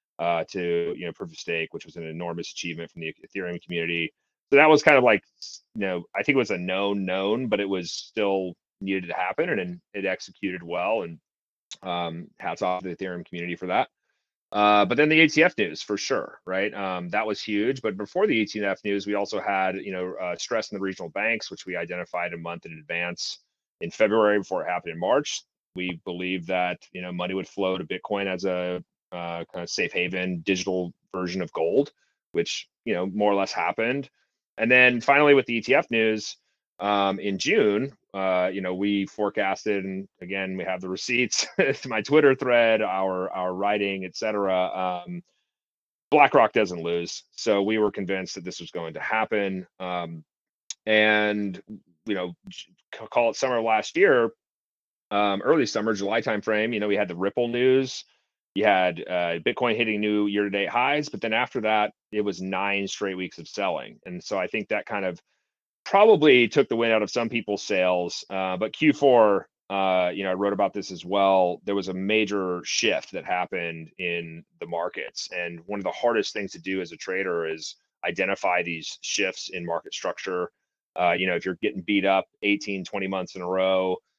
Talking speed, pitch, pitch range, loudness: 200 wpm, 95 Hz, 90-105 Hz, -25 LUFS